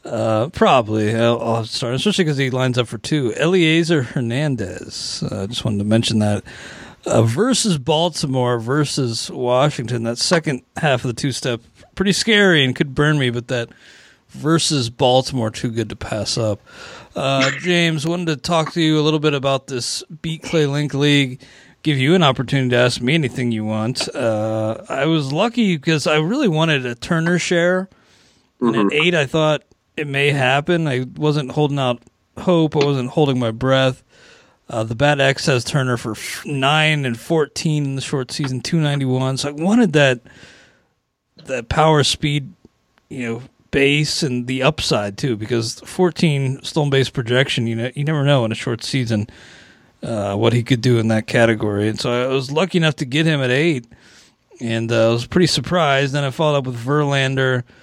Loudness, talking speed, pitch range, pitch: -18 LUFS, 185 wpm, 120-155 Hz, 135 Hz